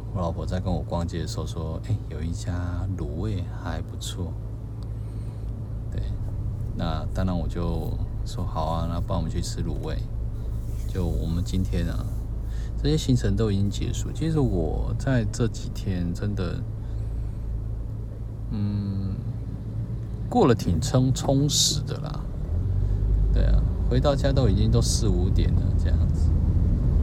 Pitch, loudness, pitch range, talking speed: 110 Hz, -27 LUFS, 90-110 Hz, 195 characters per minute